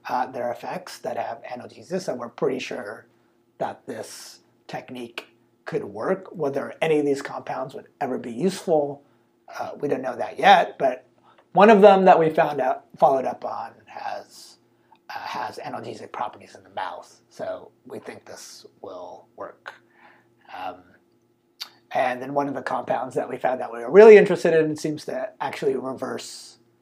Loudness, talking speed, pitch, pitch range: -21 LUFS, 170 wpm, 155 Hz, 125-190 Hz